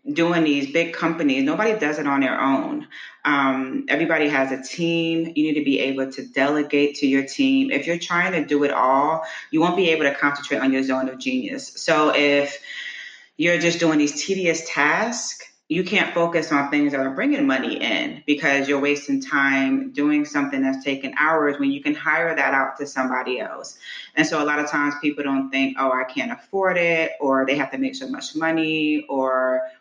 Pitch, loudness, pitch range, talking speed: 150 Hz, -21 LUFS, 140-170 Hz, 205 wpm